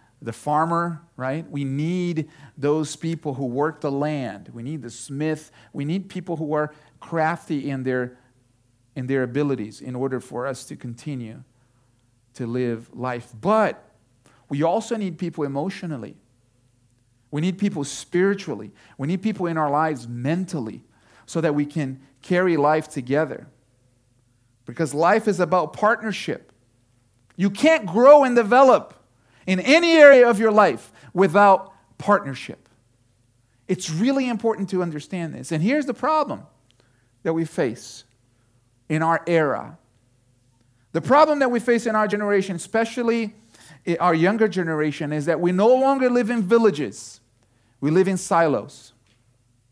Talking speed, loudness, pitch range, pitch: 140 wpm, -21 LUFS, 125-185 Hz, 150 Hz